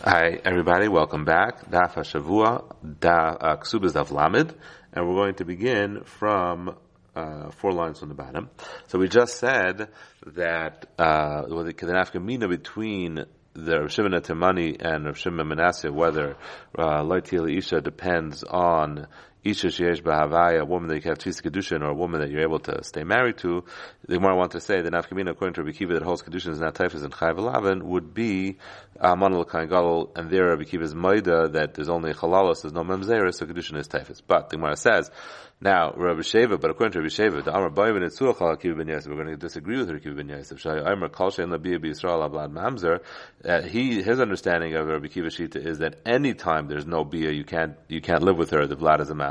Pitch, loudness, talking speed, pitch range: 85 Hz, -24 LUFS, 195 wpm, 80-90 Hz